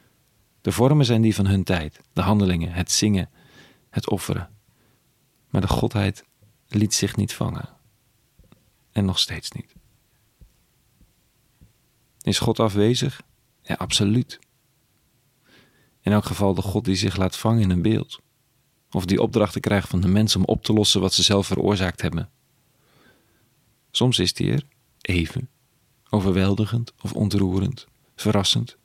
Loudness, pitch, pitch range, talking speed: -22 LUFS, 105 Hz, 95-120 Hz, 135 wpm